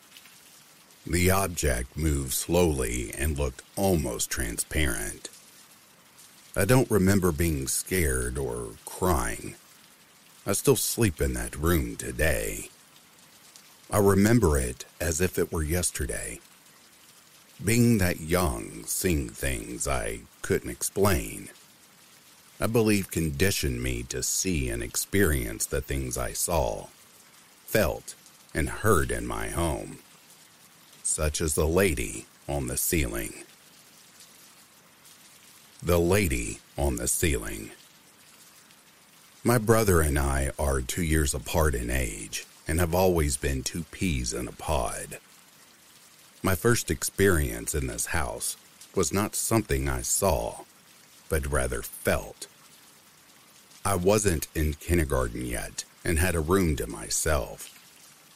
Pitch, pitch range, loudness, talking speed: 80 Hz, 70-95 Hz, -27 LUFS, 115 wpm